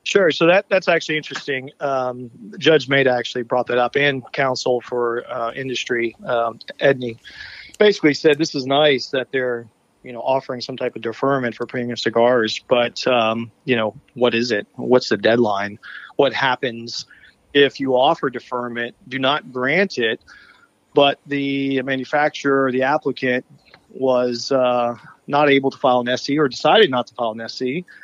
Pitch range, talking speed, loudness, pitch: 120-140 Hz, 165 wpm, -19 LUFS, 130 Hz